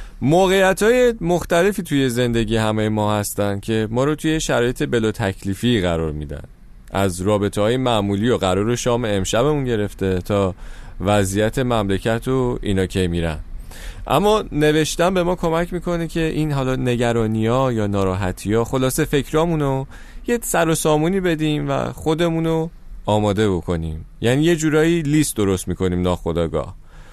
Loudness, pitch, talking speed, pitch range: -19 LUFS, 120 Hz, 140 wpm, 100-155 Hz